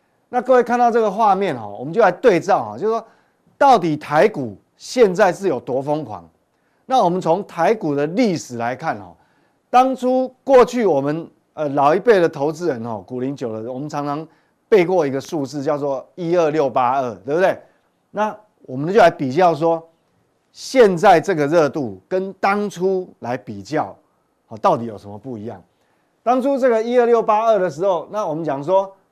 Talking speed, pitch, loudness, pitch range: 265 characters per minute, 170 Hz, -18 LUFS, 140-220 Hz